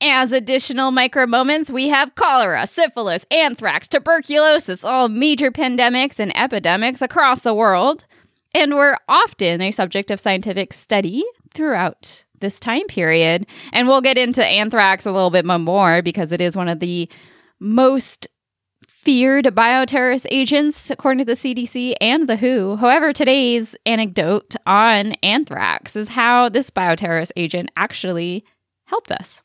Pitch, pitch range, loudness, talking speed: 245 Hz, 195-270 Hz, -16 LUFS, 140 wpm